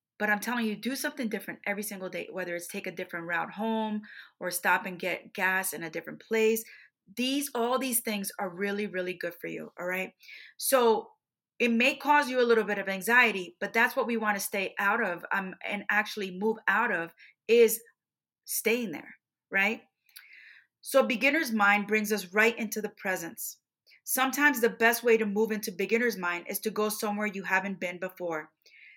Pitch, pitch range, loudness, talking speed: 210 Hz, 190-235 Hz, -28 LUFS, 195 wpm